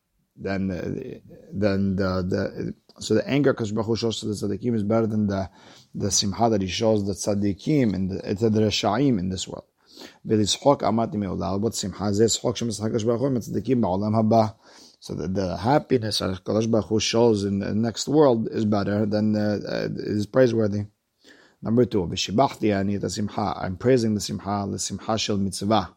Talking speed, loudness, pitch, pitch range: 135 wpm, -24 LUFS, 105 Hz, 100-115 Hz